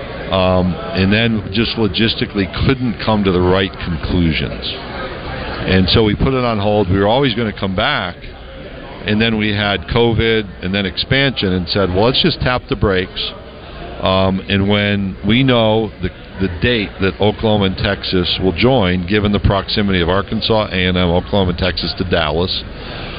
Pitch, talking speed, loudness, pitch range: 100 Hz, 170 wpm, -16 LUFS, 95-110 Hz